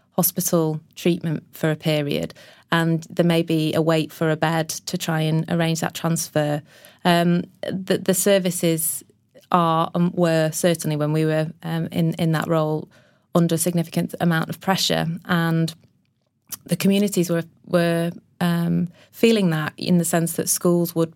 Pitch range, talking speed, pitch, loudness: 160-175 Hz, 160 wpm, 165 Hz, -21 LUFS